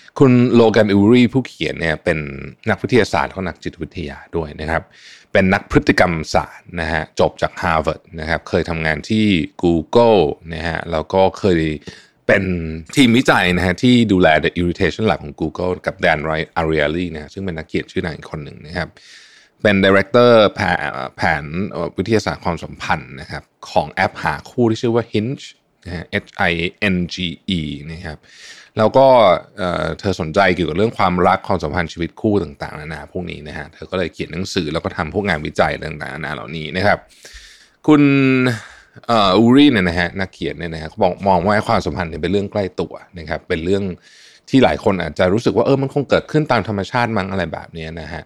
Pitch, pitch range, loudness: 90 Hz, 80-110 Hz, -17 LUFS